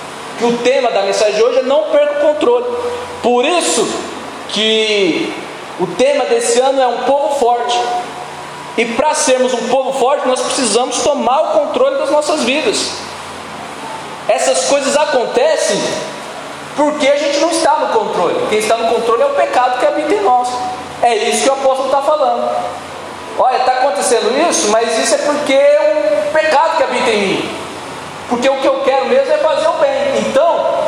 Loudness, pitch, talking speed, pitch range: -13 LUFS, 270 Hz, 175 wpm, 240-295 Hz